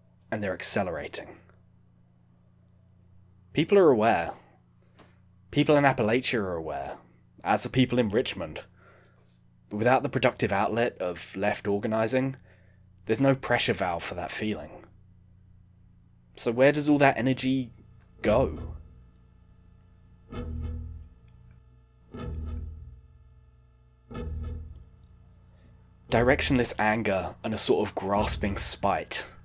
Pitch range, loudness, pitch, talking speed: 80-110 Hz, -26 LUFS, 95 Hz, 95 wpm